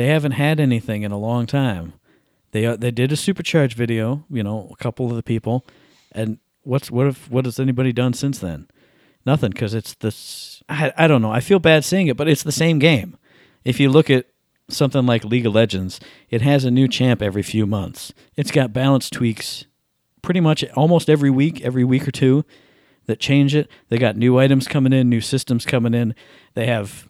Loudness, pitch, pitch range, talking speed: -19 LUFS, 130 Hz, 115-145 Hz, 210 wpm